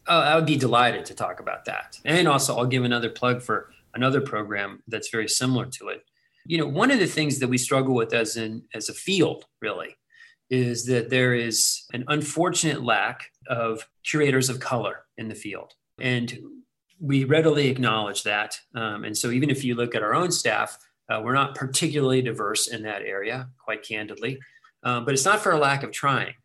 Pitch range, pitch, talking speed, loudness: 115-150 Hz, 130 Hz, 200 wpm, -24 LUFS